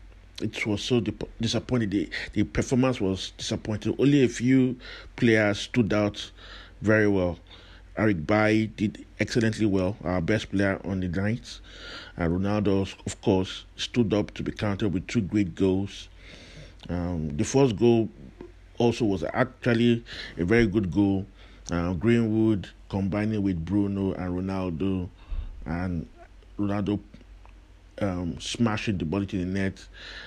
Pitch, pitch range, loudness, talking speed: 100 Hz, 90-110 Hz, -26 LUFS, 135 wpm